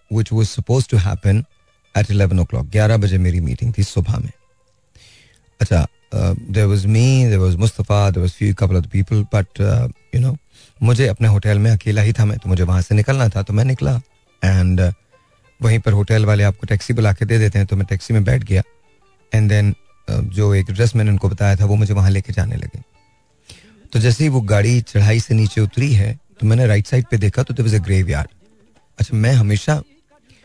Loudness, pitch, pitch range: -17 LUFS, 110 Hz, 100-115 Hz